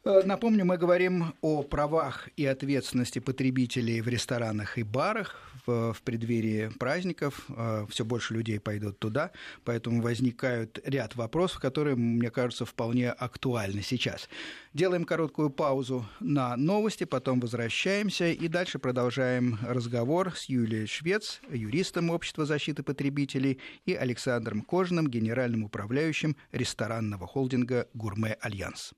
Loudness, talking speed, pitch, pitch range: -30 LUFS, 120 wpm, 130 Hz, 115-155 Hz